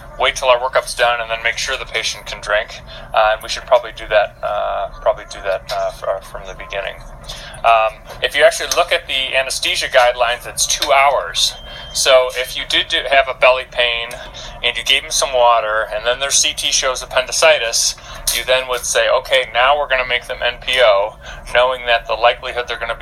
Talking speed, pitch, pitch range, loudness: 210 wpm, 125 Hz, 120-140 Hz, -15 LUFS